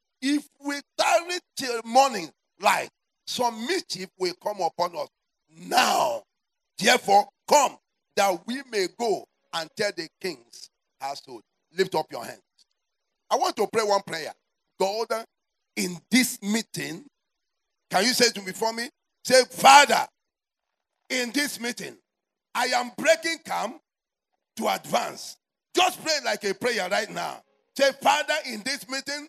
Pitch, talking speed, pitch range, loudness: 245 Hz, 140 wpm, 200-290 Hz, -24 LUFS